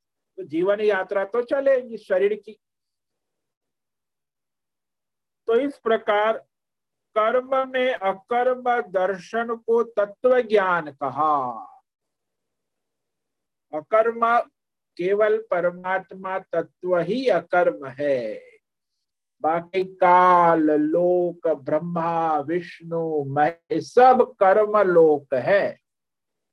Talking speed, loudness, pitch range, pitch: 80 wpm, -22 LUFS, 170-230 Hz, 195 Hz